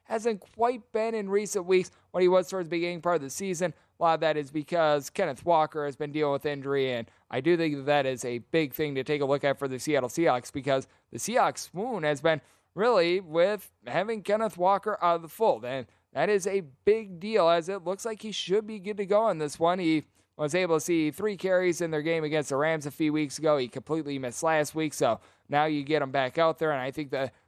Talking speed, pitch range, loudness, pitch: 250 wpm, 145-185 Hz, -28 LUFS, 160 Hz